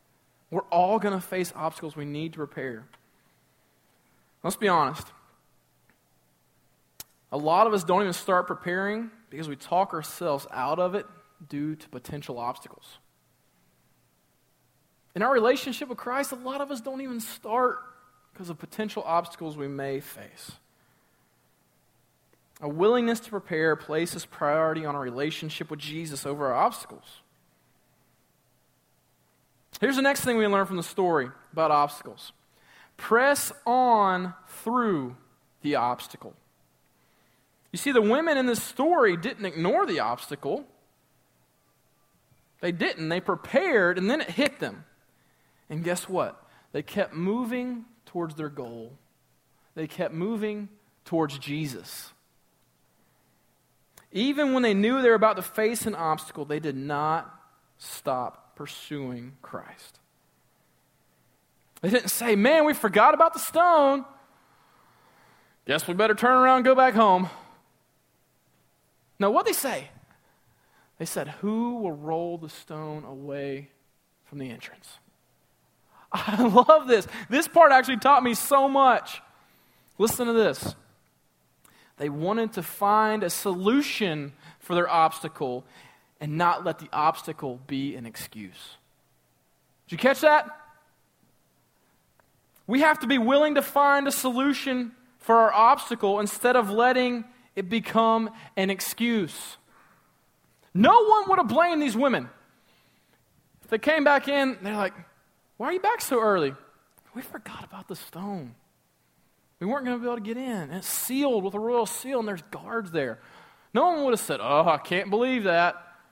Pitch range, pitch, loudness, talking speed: 155-245 Hz, 195 Hz, -25 LUFS, 140 wpm